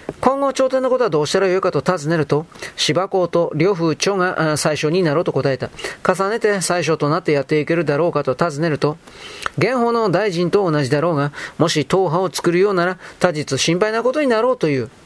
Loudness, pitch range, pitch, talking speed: -18 LUFS, 150-200 Hz, 175 Hz, 395 characters per minute